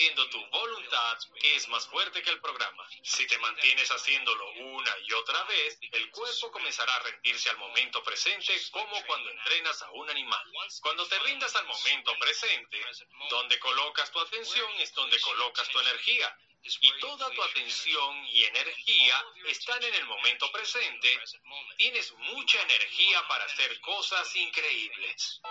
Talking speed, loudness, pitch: 150 wpm, -27 LUFS, 225 Hz